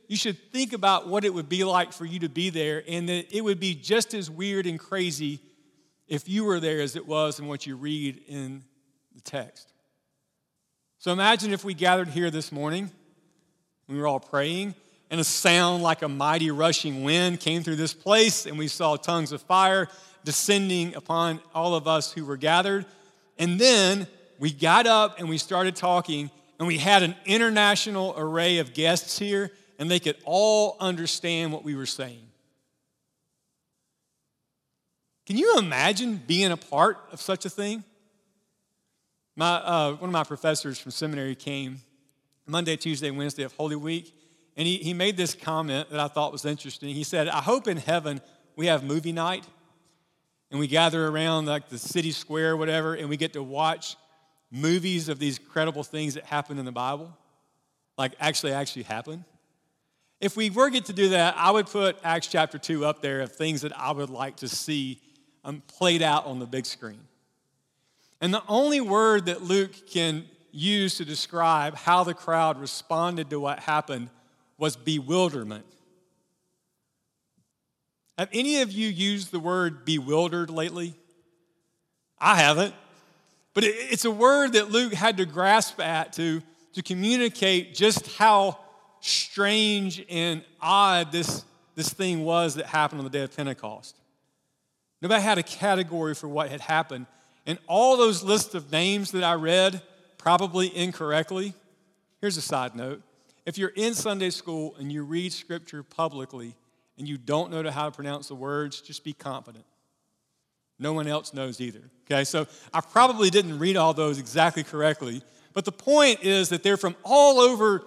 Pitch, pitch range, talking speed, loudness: 165 Hz, 150-190 Hz, 170 wpm, -25 LUFS